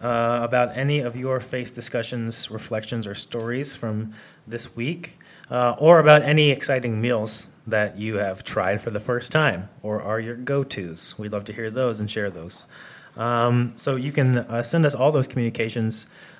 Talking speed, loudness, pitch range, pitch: 185 wpm, -22 LUFS, 110-135 Hz, 120 Hz